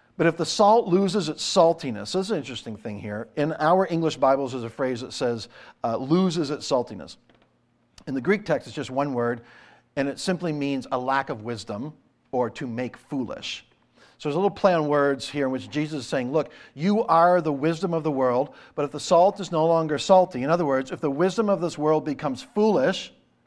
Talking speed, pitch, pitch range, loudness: 220 wpm, 150 Hz, 130-175 Hz, -24 LUFS